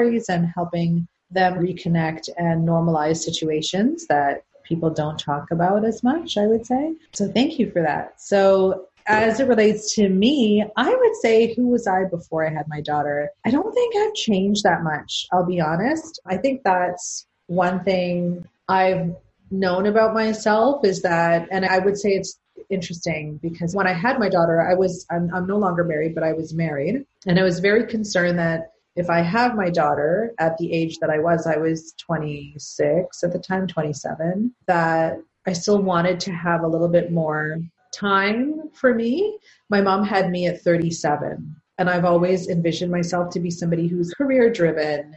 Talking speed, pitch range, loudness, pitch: 180 wpm, 165-210 Hz, -21 LUFS, 180 Hz